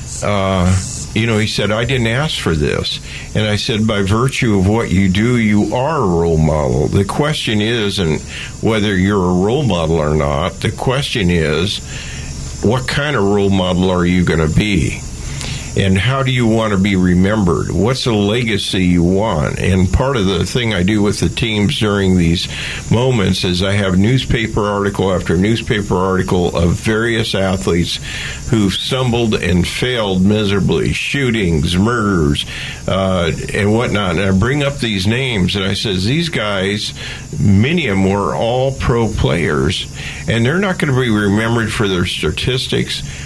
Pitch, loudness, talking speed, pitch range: 100 Hz, -15 LUFS, 170 wpm, 90-110 Hz